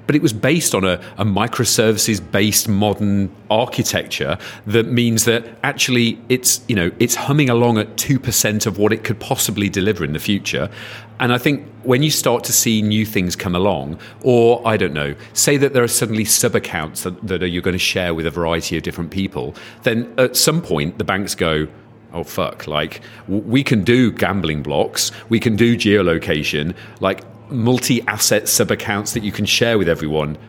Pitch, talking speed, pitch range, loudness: 110 Hz, 195 wpm, 95-120 Hz, -17 LUFS